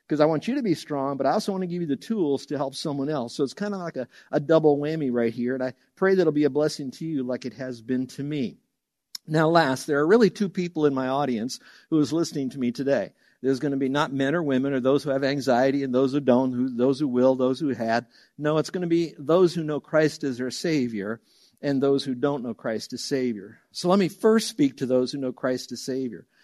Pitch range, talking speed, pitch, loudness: 130-155 Hz, 270 wpm, 140 Hz, -25 LUFS